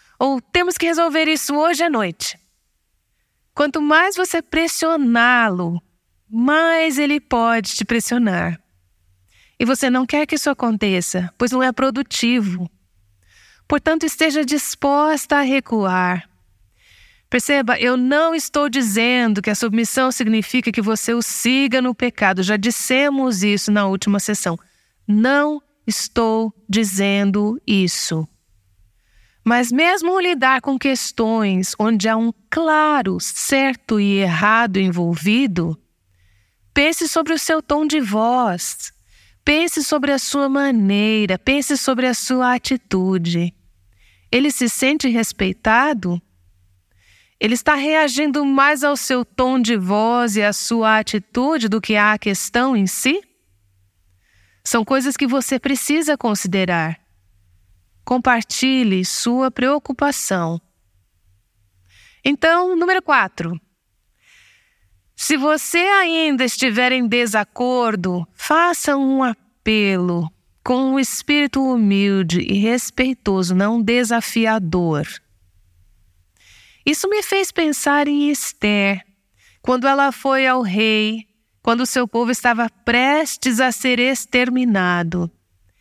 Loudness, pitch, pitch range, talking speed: -17 LUFS, 235 Hz, 185-275 Hz, 110 wpm